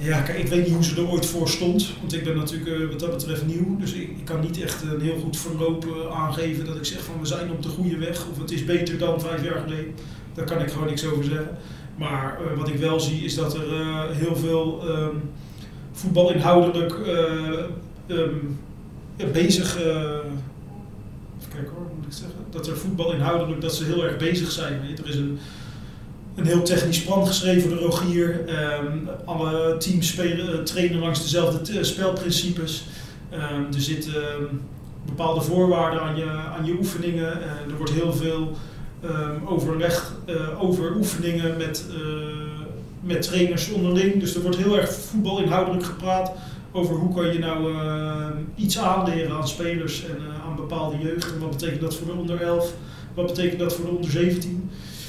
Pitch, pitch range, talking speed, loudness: 165 Hz, 155-175 Hz, 185 wpm, -24 LUFS